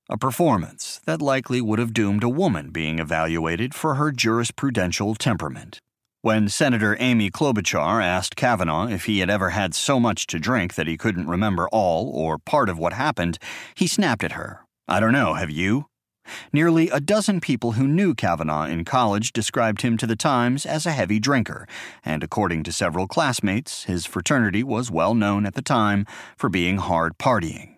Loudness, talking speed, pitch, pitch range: -22 LUFS, 180 wpm, 110 Hz, 90-125 Hz